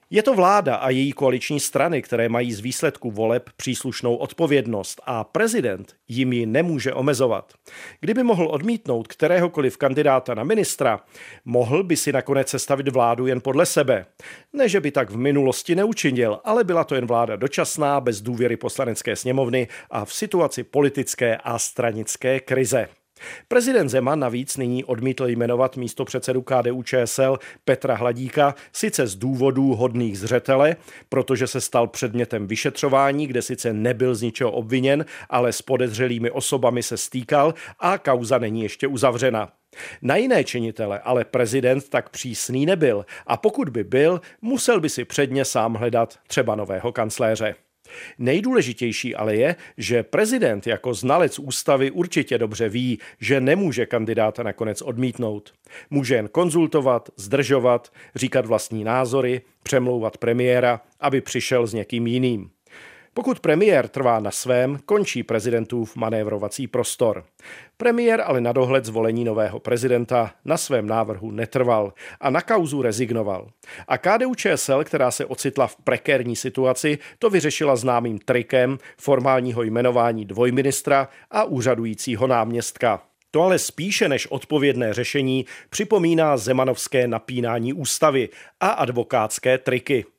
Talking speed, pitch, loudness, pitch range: 135 wpm, 130 Hz, -21 LUFS, 120-140 Hz